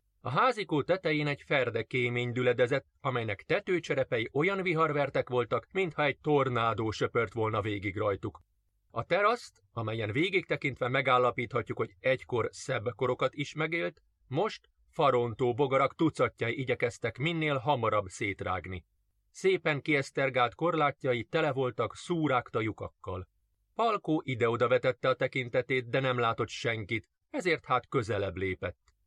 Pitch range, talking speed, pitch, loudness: 110-155 Hz, 120 wpm, 130 Hz, -30 LUFS